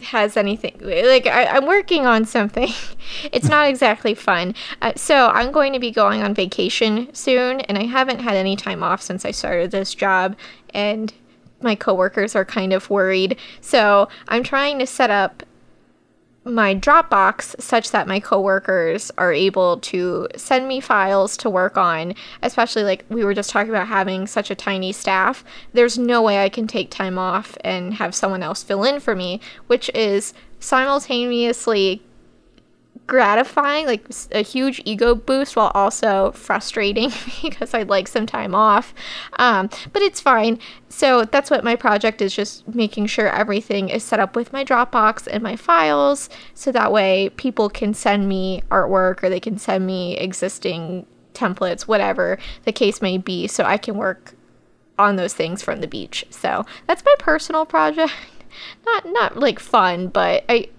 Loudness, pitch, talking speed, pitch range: -18 LUFS, 215 Hz, 170 wpm, 195-250 Hz